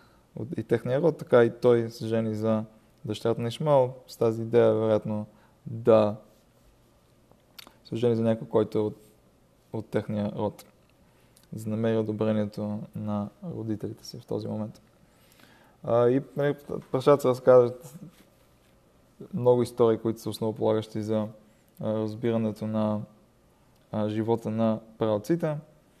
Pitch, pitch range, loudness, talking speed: 110 Hz, 110-120 Hz, -27 LUFS, 125 wpm